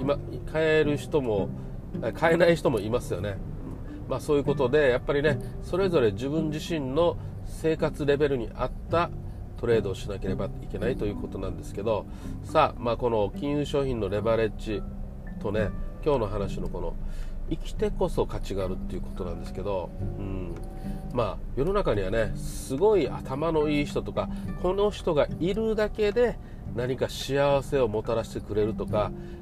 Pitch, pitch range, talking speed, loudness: 125 Hz, 100-155 Hz, 340 characters per minute, -28 LUFS